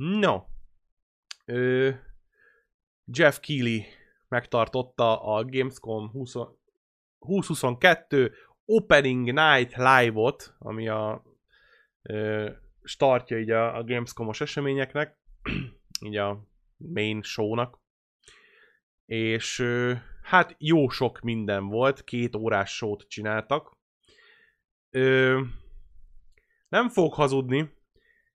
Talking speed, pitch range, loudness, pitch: 85 wpm, 110-145 Hz, -25 LUFS, 125 Hz